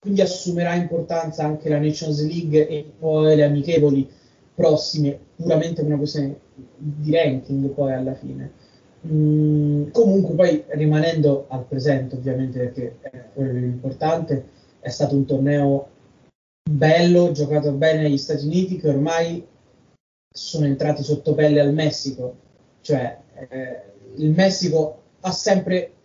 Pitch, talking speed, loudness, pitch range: 150 Hz, 130 wpm, -20 LUFS, 140-160 Hz